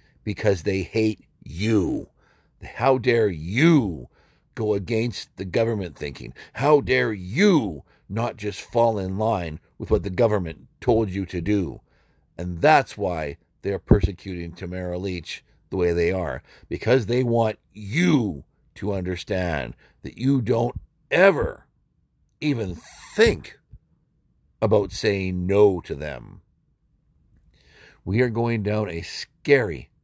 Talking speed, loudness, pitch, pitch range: 125 wpm, -23 LUFS, 100 Hz, 90-115 Hz